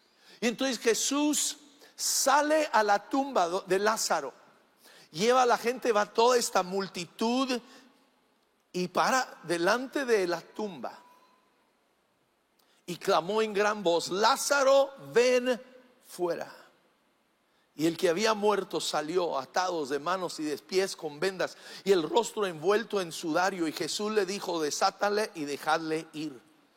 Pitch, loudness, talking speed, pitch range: 210 Hz, -28 LUFS, 130 wpm, 175-250 Hz